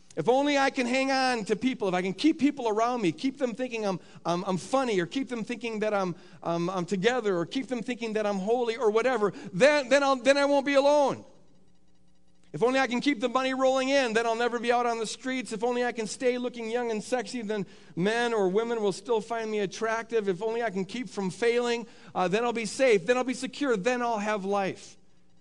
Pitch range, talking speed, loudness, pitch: 200-255 Hz, 245 wpm, -27 LUFS, 230 Hz